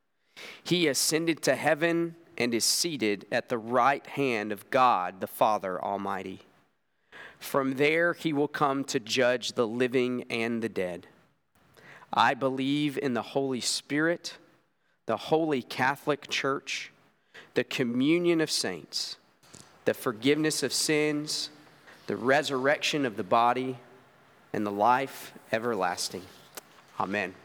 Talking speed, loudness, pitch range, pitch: 120 wpm, -28 LUFS, 125-155 Hz, 140 Hz